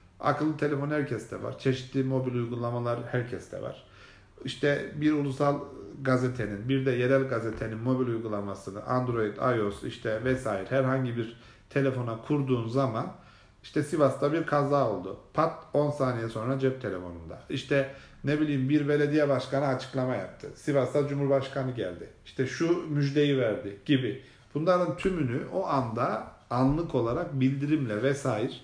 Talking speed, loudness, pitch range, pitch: 130 wpm, -29 LUFS, 120-145 Hz, 130 Hz